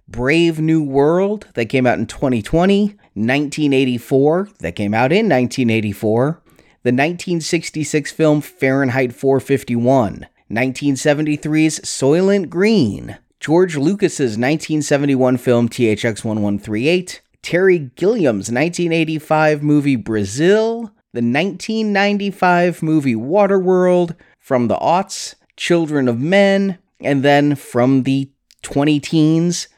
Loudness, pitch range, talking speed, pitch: -16 LUFS, 130-175 Hz, 100 wpm, 150 Hz